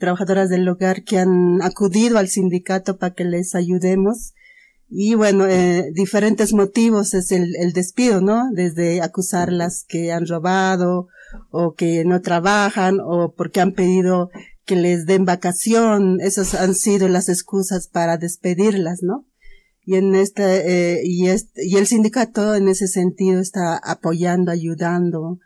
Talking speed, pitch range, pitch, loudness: 145 wpm, 175-200 Hz, 185 Hz, -18 LUFS